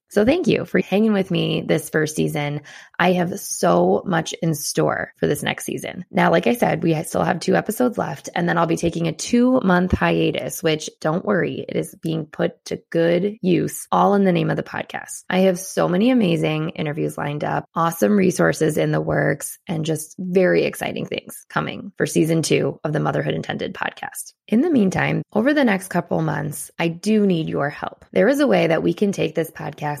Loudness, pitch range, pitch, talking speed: -20 LUFS, 155-195 Hz, 170 Hz, 210 wpm